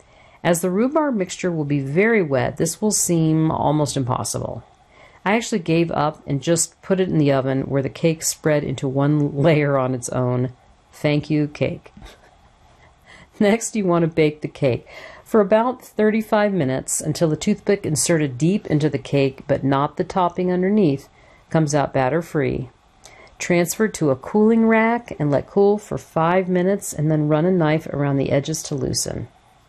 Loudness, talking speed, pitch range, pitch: -20 LUFS, 175 wpm, 140-190 Hz, 160 Hz